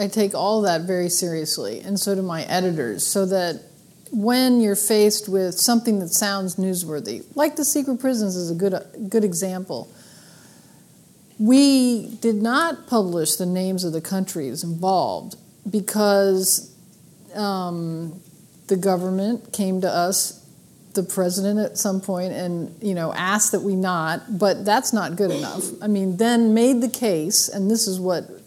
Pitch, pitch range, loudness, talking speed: 195 Hz, 180-215 Hz, -21 LUFS, 155 wpm